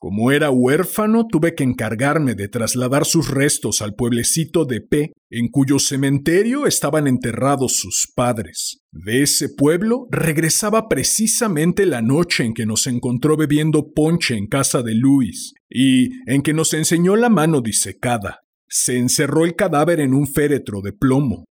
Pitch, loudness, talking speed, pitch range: 145 Hz, -17 LUFS, 155 wpm, 125-165 Hz